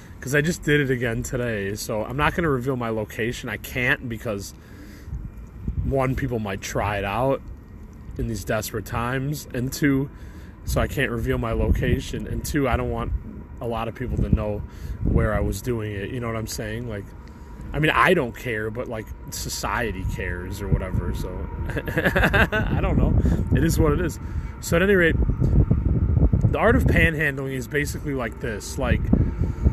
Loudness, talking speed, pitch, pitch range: -24 LUFS, 185 wpm, 110 Hz, 100-125 Hz